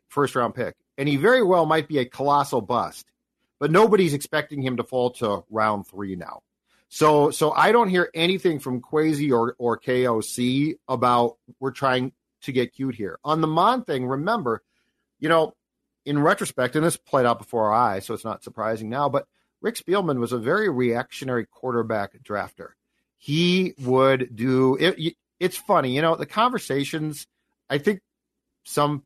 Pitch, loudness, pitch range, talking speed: 140 Hz, -23 LUFS, 125-160 Hz, 170 wpm